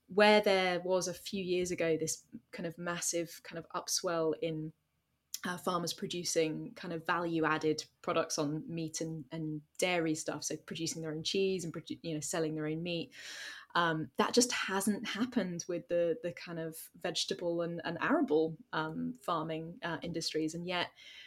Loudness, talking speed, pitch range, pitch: -35 LUFS, 170 wpm, 160-180 Hz, 170 Hz